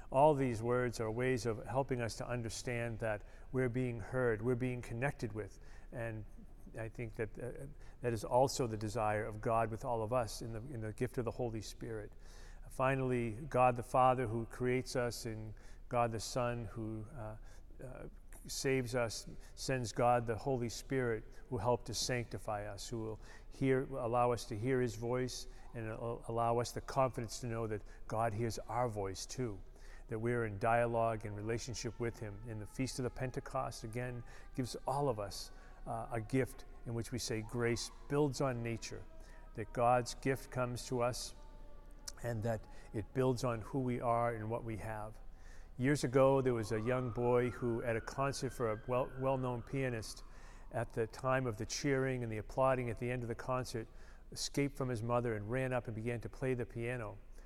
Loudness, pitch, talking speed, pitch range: -38 LUFS, 120 Hz, 195 wpm, 110-125 Hz